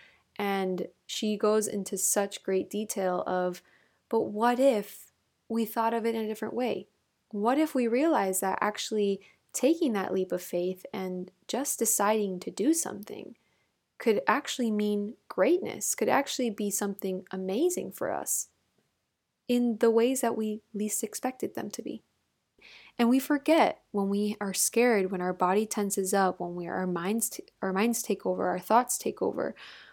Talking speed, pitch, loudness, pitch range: 165 wpm, 210 Hz, -29 LUFS, 190-235 Hz